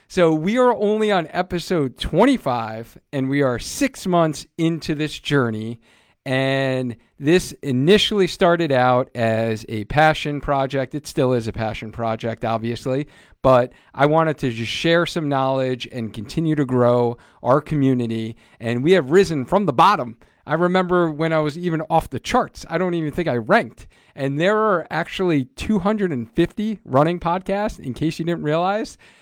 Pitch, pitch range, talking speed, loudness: 150 Hz, 125-175 Hz, 160 wpm, -20 LUFS